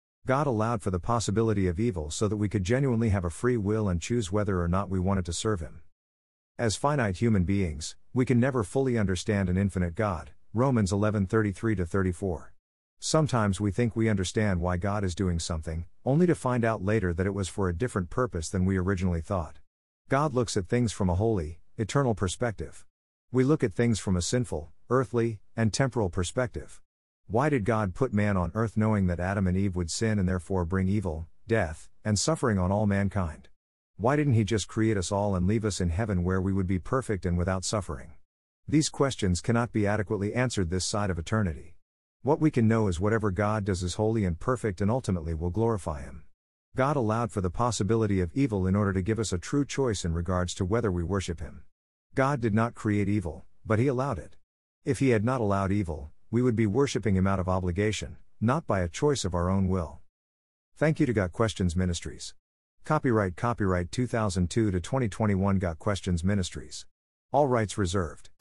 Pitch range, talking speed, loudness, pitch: 90-115 Hz, 200 wpm, -28 LUFS, 100 Hz